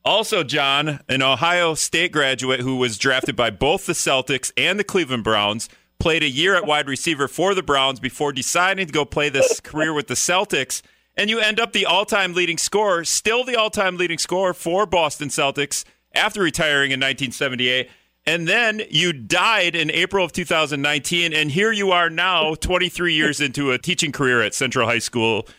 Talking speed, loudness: 190 wpm, -19 LUFS